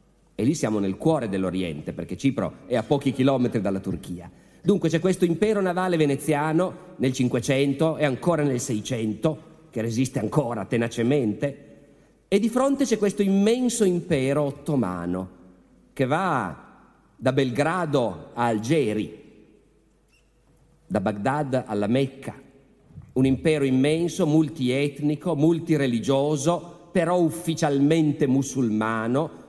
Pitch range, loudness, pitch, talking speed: 120-160 Hz, -24 LUFS, 140 Hz, 115 wpm